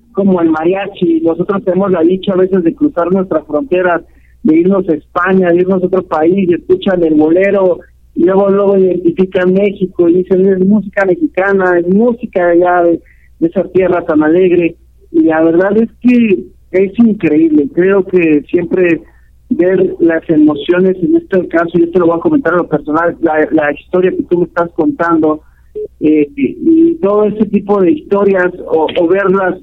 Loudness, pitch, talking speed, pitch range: -11 LUFS, 180 Hz, 180 wpm, 165-195 Hz